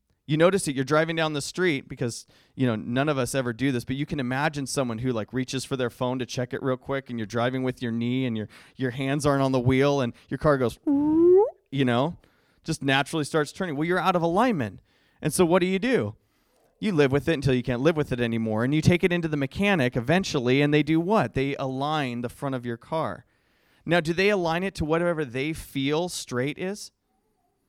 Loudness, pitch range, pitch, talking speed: -25 LUFS, 125-160 Hz, 140 Hz, 235 wpm